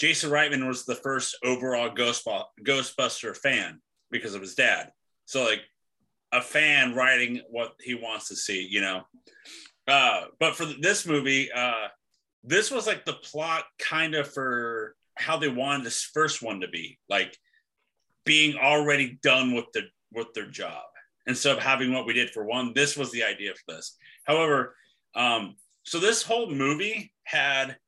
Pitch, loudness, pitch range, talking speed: 135 Hz, -25 LUFS, 125-150 Hz, 165 wpm